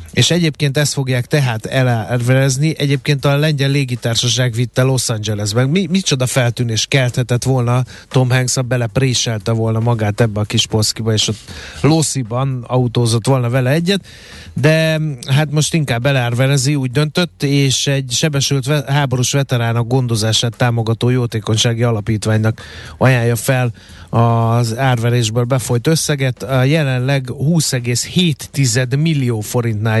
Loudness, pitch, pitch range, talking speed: -15 LUFS, 125 Hz, 115-140 Hz, 120 wpm